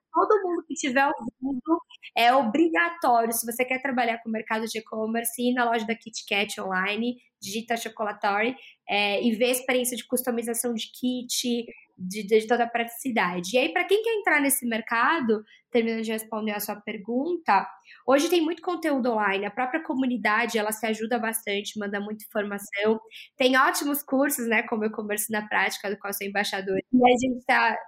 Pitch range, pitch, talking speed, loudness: 215-260 Hz, 235 Hz, 180 wpm, -25 LUFS